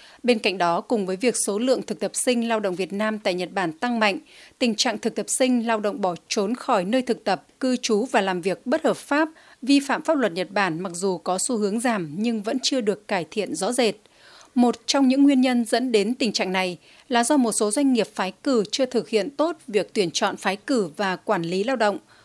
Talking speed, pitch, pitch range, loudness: 250 wpm, 225 Hz, 195-255 Hz, -23 LUFS